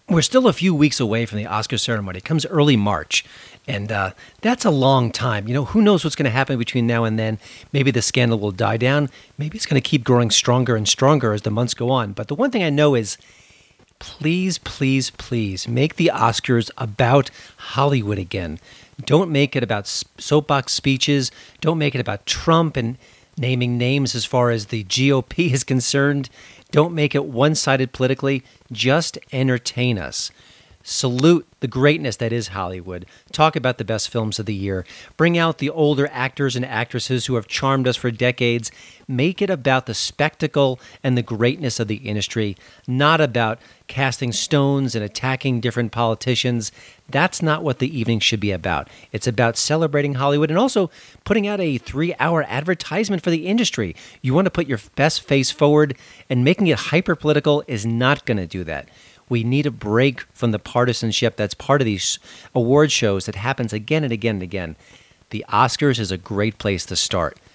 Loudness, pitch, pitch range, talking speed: -20 LUFS, 125 Hz, 115-145 Hz, 190 wpm